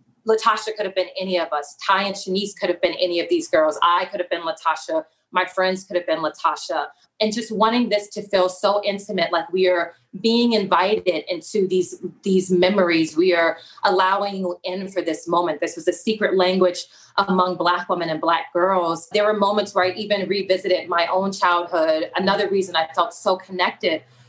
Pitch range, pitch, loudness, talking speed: 175-200 Hz, 185 Hz, -21 LUFS, 195 wpm